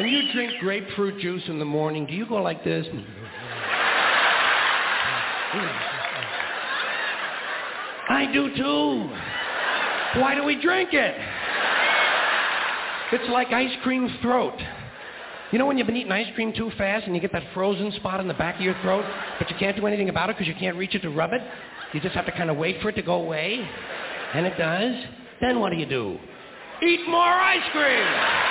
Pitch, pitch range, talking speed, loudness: 205 Hz, 175-245 Hz, 185 wpm, -24 LUFS